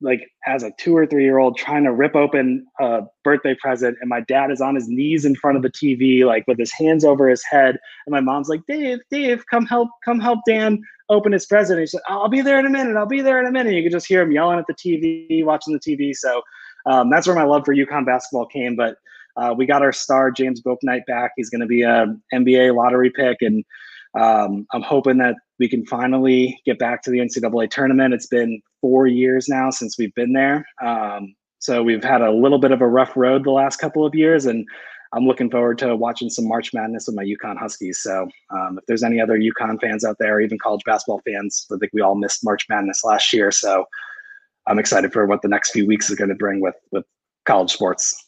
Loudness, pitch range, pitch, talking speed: -18 LUFS, 120-155 Hz, 130 Hz, 240 wpm